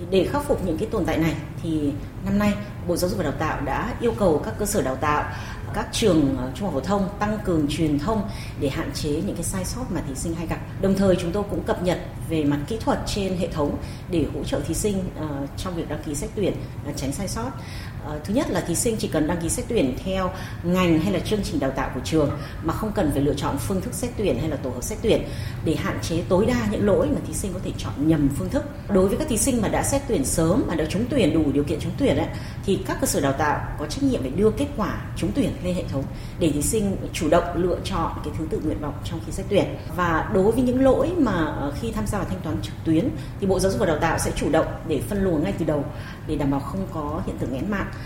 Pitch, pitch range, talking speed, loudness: 145 Hz, 135-170 Hz, 275 wpm, -24 LUFS